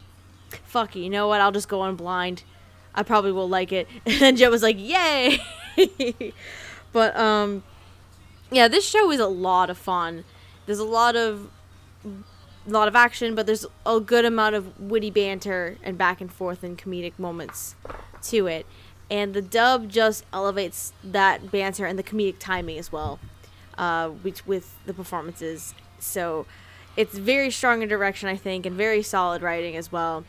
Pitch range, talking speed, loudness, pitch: 170-220 Hz, 175 wpm, -23 LUFS, 190 Hz